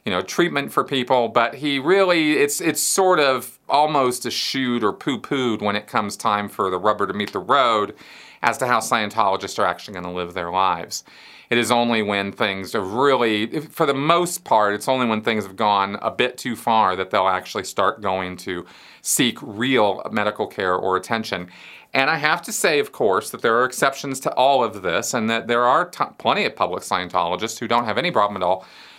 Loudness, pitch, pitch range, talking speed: -20 LUFS, 110 Hz, 100-130 Hz, 215 wpm